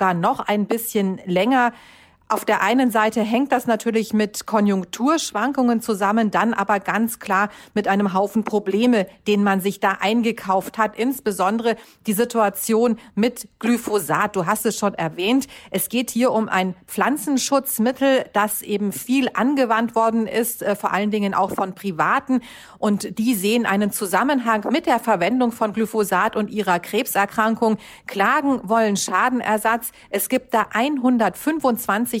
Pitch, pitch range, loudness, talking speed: 220 Hz, 200-235 Hz, -20 LUFS, 140 wpm